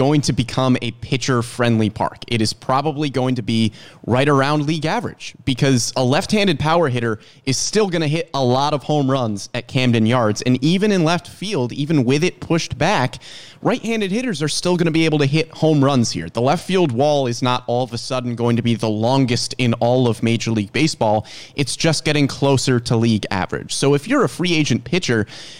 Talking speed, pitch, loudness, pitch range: 225 wpm, 135 Hz, -18 LUFS, 120-155 Hz